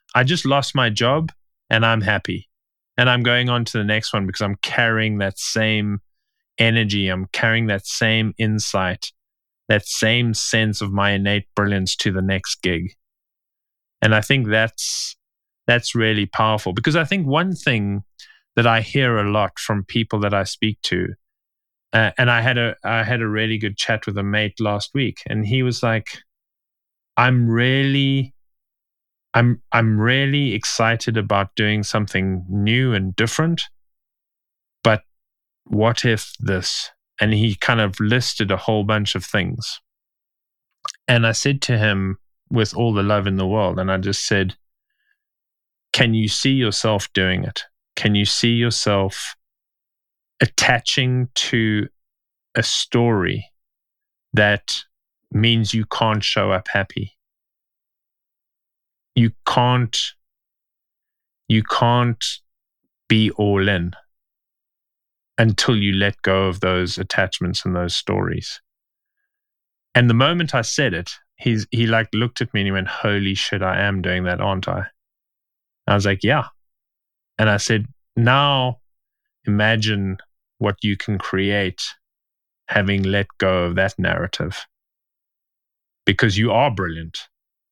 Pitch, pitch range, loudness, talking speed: 110 Hz, 100-120 Hz, -19 LUFS, 140 wpm